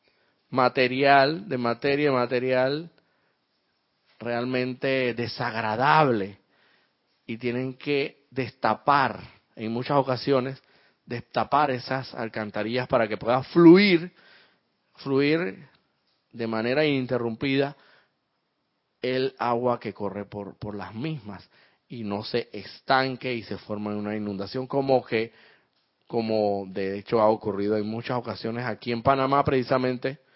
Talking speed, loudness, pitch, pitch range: 110 wpm, -25 LUFS, 125 Hz, 110-135 Hz